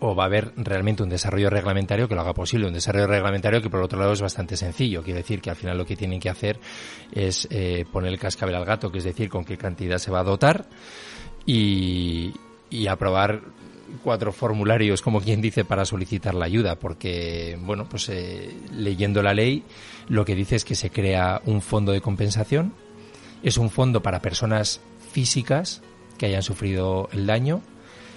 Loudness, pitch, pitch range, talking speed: -24 LUFS, 100 Hz, 95-110 Hz, 190 wpm